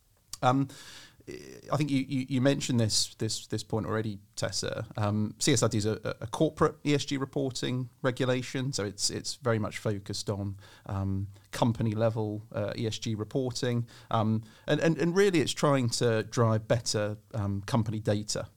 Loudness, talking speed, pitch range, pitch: -30 LUFS, 155 wpm, 105-130 Hz, 115 Hz